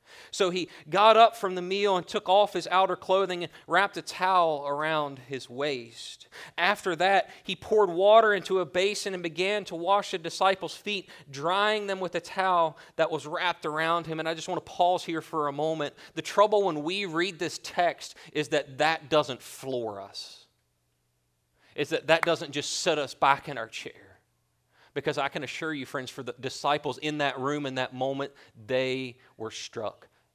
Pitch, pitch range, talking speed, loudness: 165 Hz, 140-190 Hz, 190 wpm, -27 LUFS